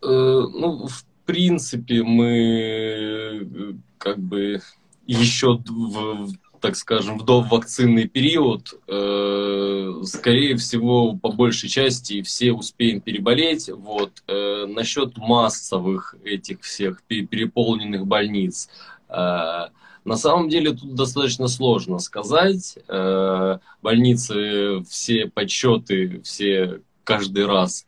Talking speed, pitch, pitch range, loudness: 90 wpm, 115 Hz, 100-125 Hz, -21 LUFS